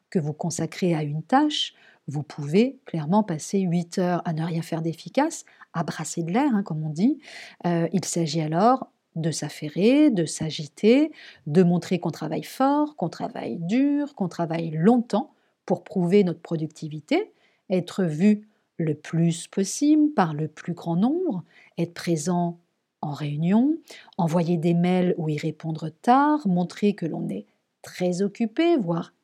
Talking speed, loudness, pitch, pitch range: 155 wpm, -24 LUFS, 180 Hz, 165-230 Hz